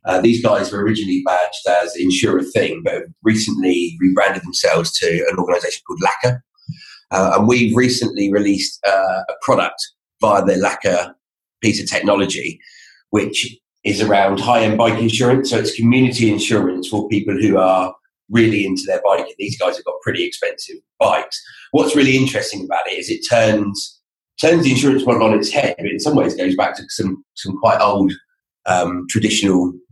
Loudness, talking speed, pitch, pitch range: -16 LUFS, 170 wpm, 110 Hz, 100-130 Hz